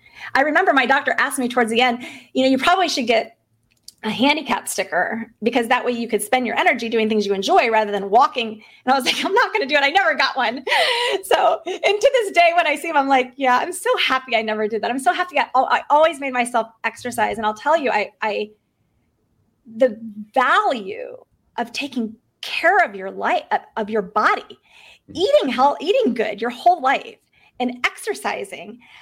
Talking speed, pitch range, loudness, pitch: 205 wpm, 225-330 Hz, -19 LUFS, 255 Hz